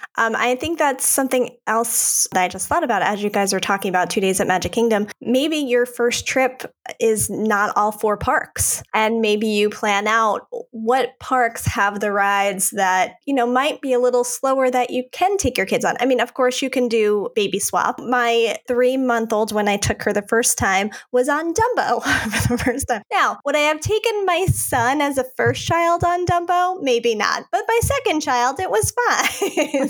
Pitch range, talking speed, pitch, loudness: 210-275 Hz, 210 wpm, 245 Hz, -19 LUFS